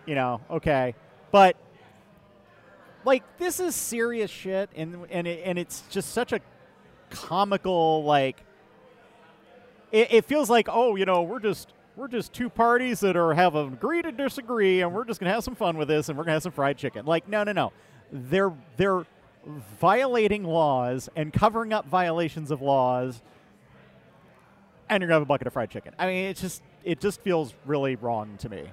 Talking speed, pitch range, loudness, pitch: 185 wpm, 150-215 Hz, -25 LUFS, 175 Hz